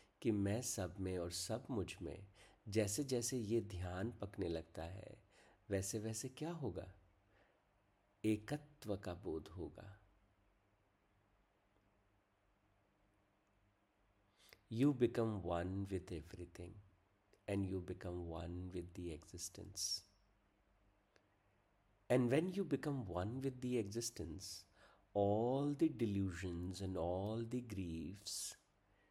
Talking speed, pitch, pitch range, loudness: 105 wpm, 100 Hz, 95-110 Hz, -43 LUFS